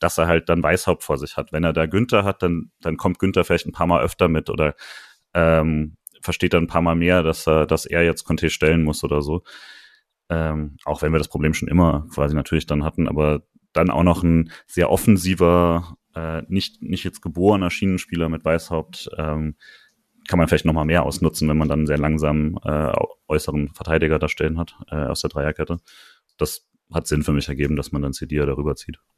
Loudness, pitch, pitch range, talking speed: -21 LUFS, 80 Hz, 75-85 Hz, 210 wpm